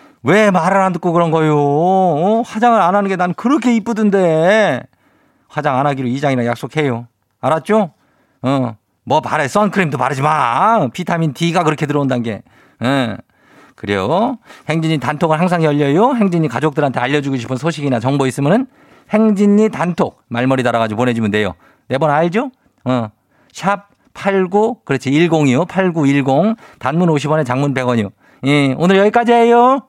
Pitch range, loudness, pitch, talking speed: 130-195 Hz, -15 LUFS, 155 Hz, 305 characters per minute